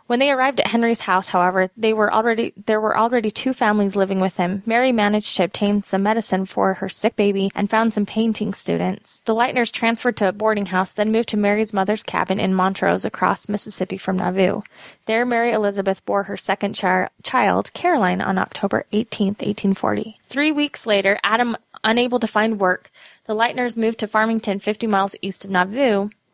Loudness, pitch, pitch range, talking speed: -20 LUFS, 210 Hz, 195-225 Hz, 190 wpm